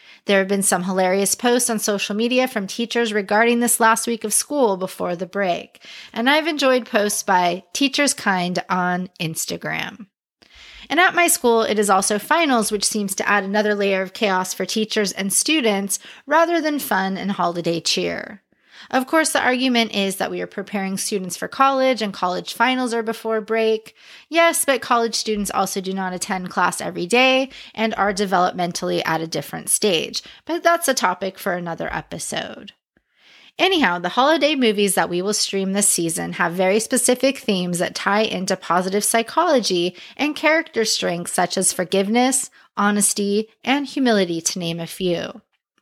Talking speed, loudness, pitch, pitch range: 170 wpm, -19 LUFS, 210 Hz, 185-250 Hz